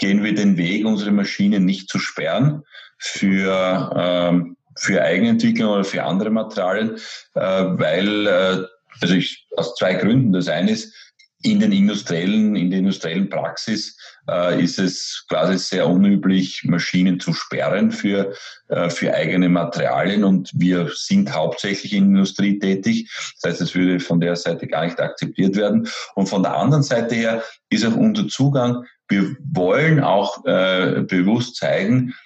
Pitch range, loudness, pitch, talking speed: 95-150 Hz, -19 LUFS, 100 Hz, 150 wpm